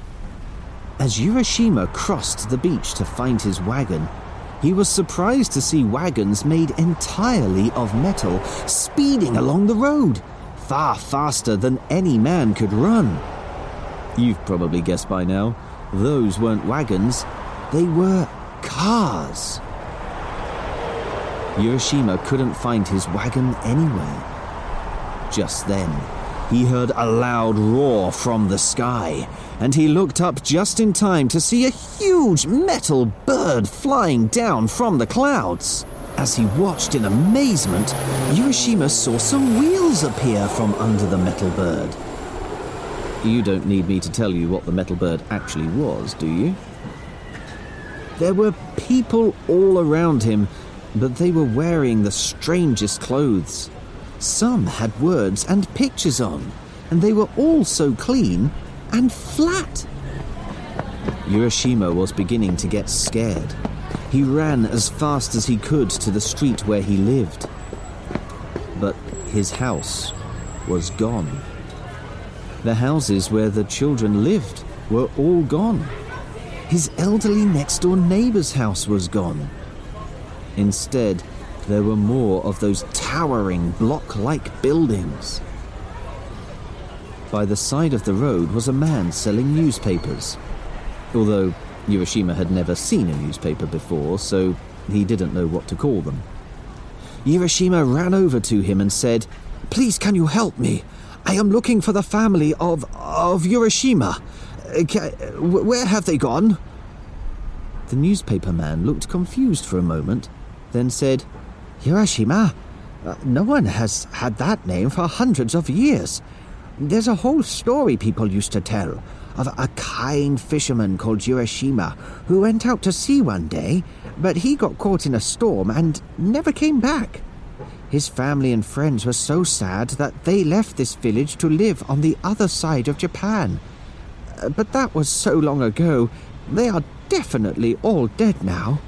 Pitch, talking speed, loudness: 120 Hz, 135 wpm, -20 LUFS